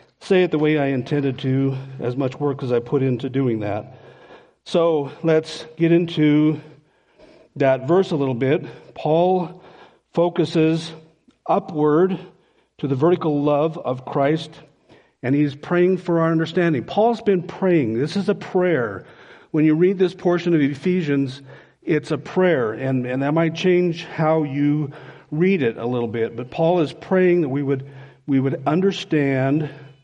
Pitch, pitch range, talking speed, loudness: 155 Hz, 140-175 Hz, 165 wpm, -20 LUFS